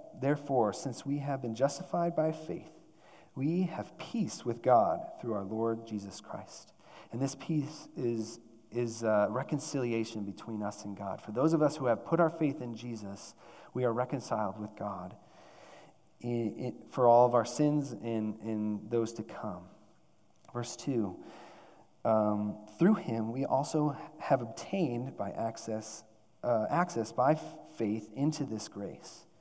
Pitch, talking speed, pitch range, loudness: 120 Hz, 155 wpm, 110-145 Hz, -33 LUFS